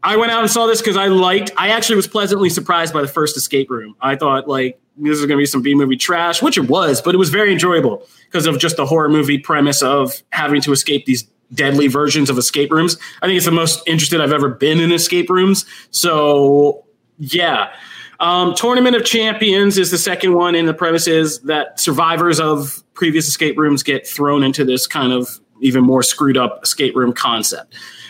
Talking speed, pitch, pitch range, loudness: 215 wpm, 155 Hz, 140-180 Hz, -14 LUFS